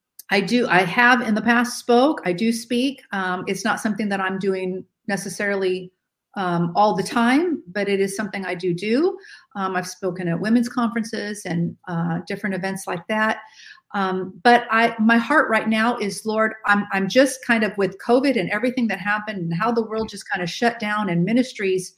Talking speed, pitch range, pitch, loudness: 200 wpm, 190-235 Hz, 210 Hz, -21 LUFS